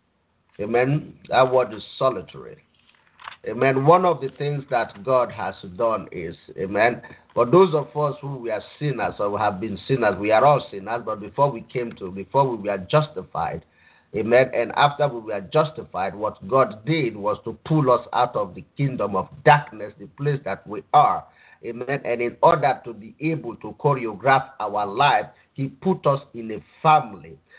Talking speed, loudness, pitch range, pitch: 180 wpm, -22 LUFS, 110-145 Hz, 130 Hz